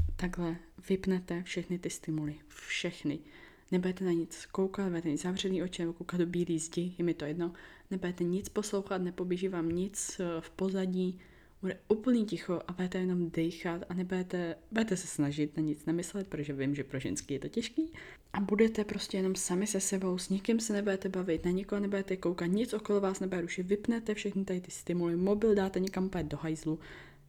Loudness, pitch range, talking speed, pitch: -34 LUFS, 170-195 Hz, 185 wpm, 180 Hz